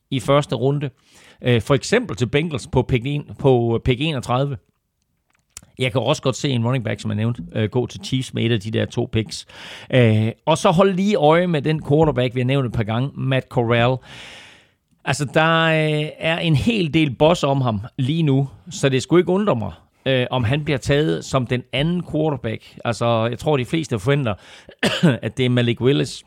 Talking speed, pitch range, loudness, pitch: 190 wpm, 120-150 Hz, -20 LUFS, 130 Hz